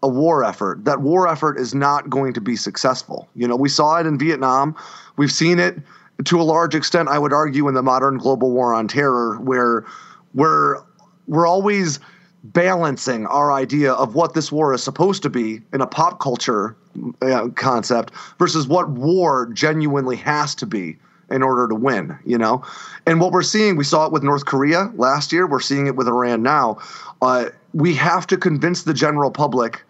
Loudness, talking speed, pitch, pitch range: -18 LUFS, 195 wpm, 145 Hz, 130-165 Hz